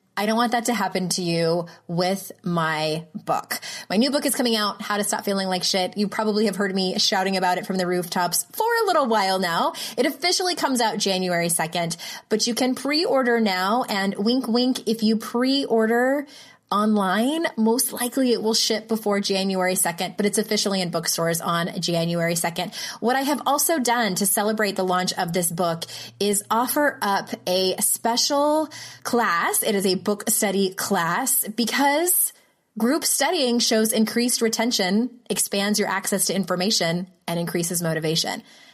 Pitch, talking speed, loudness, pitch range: 210 Hz, 175 wpm, -22 LUFS, 185-240 Hz